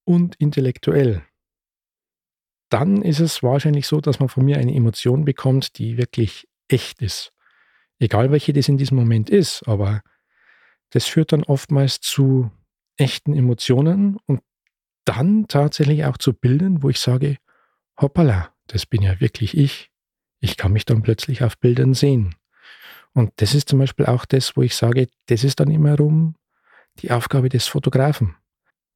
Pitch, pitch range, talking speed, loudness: 135 Hz, 120-145 Hz, 155 wpm, -19 LUFS